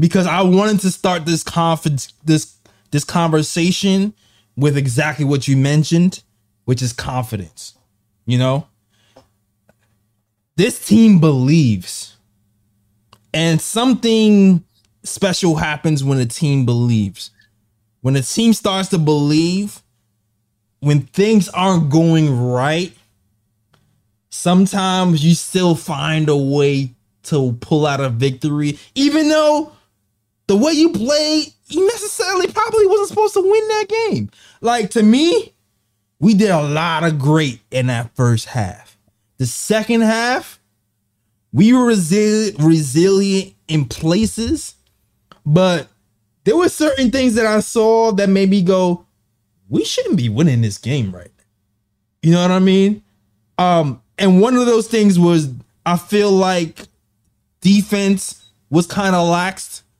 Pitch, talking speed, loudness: 155 Hz, 130 wpm, -15 LUFS